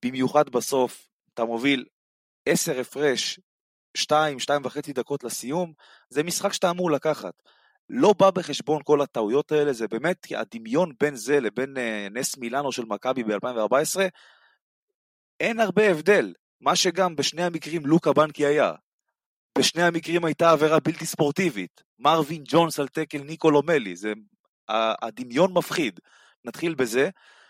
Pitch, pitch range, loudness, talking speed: 150 Hz, 130-175 Hz, -24 LUFS, 130 wpm